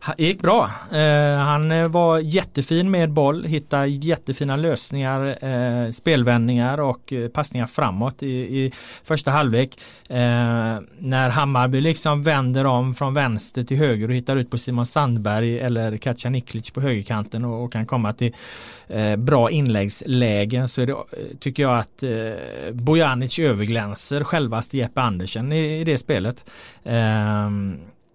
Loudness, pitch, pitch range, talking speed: -21 LUFS, 130 Hz, 120-150 Hz, 140 wpm